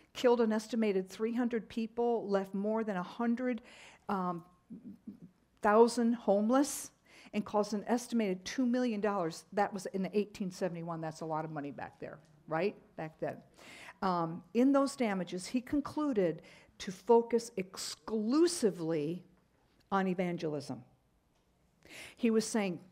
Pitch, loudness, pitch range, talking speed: 205 Hz, -34 LUFS, 180-235 Hz, 120 wpm